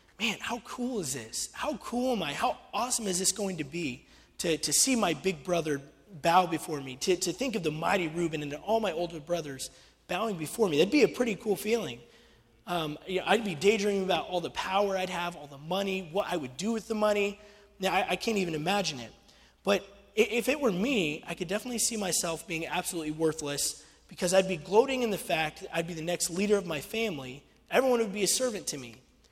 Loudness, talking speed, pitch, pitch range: -30 LUFS, 225 wpm, 185 Hz, 160-205 Hz